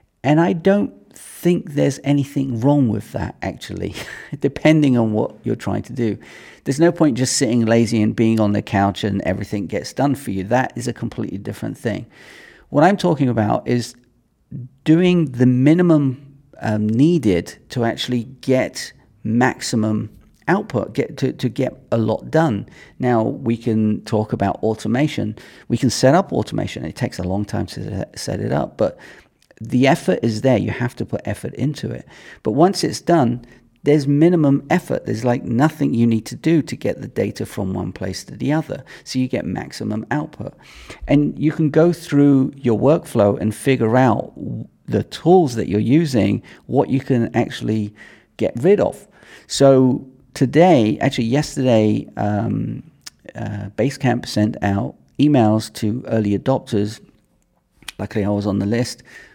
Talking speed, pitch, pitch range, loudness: 165 wpm, 120 Hz, 110-140 Hz, -19 LUFS